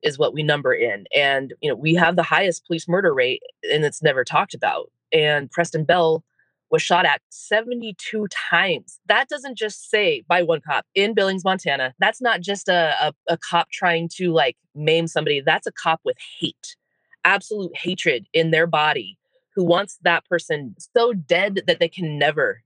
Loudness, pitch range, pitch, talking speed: -20 LUFS, 165-220 Hz, 175 Hz, 185 wpm